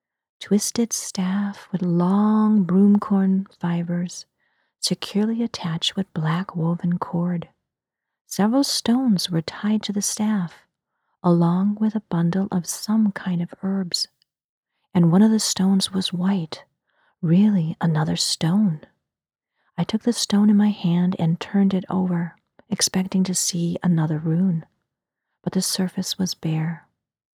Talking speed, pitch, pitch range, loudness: 130 wpm, 185 Hz, 170-205 Hz, -22 LUFS